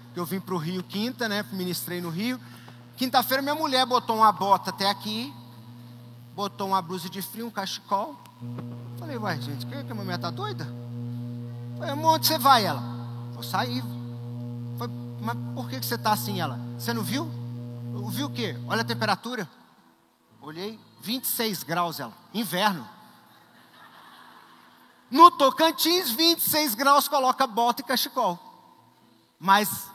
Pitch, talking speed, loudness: 175 Hz, 150 wpm, -25 LUFS